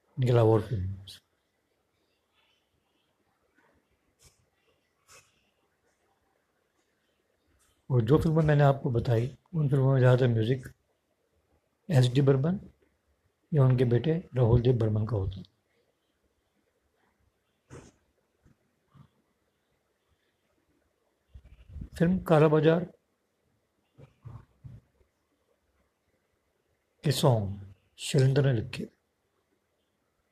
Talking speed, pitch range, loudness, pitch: 60 wpm, 105-145 Hz, -26 LUFS, 125 Hz